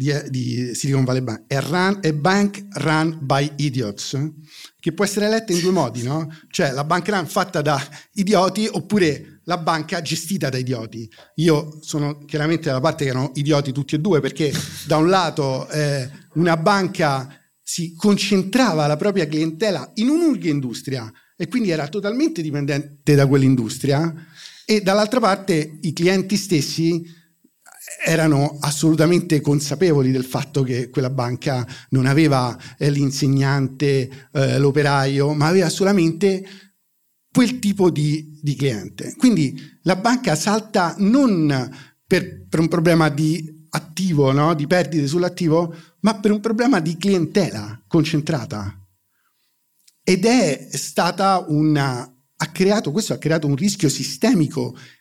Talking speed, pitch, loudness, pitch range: 135 wpm, 155 Hz, -20 LUFS, 140-185 Hz